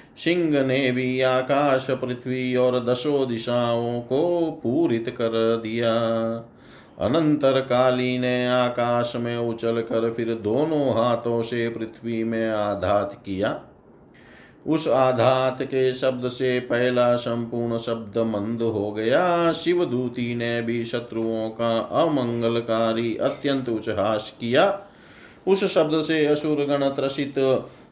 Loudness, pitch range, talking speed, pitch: -23 LUFS, 115-130 Hz, 115 wpm, 120 Hz